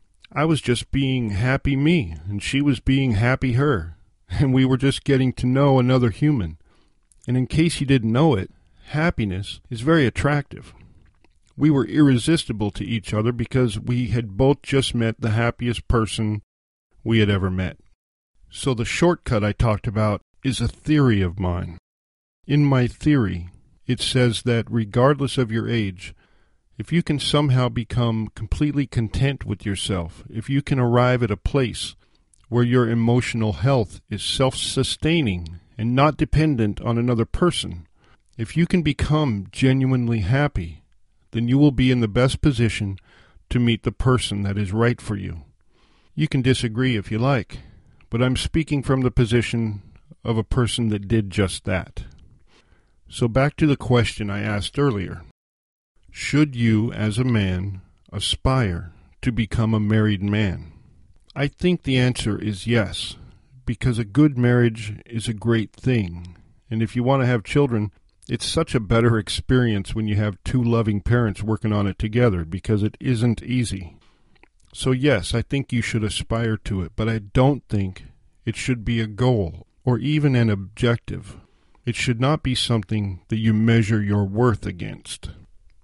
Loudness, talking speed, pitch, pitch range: -21 LUFS, 165 wpm, 115 Hz, 100-130 Hz